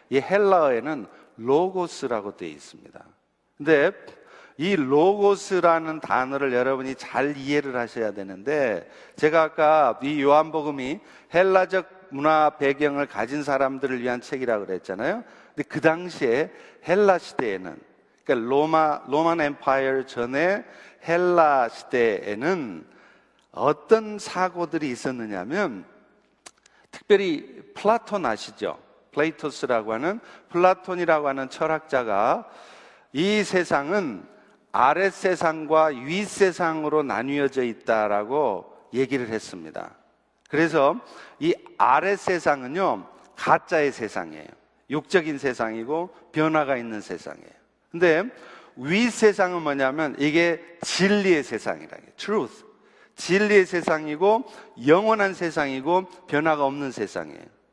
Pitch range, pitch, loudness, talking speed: 135-185 Hz, 155 Hz, -23 LUFS, 270 characters per minute